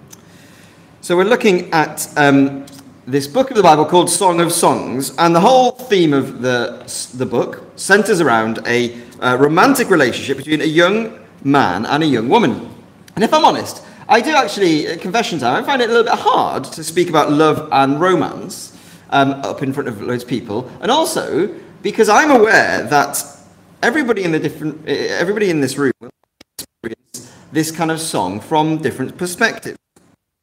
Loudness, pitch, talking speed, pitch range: -15 LUFS, 155 Hz, 175 wpm, 140-205 Hz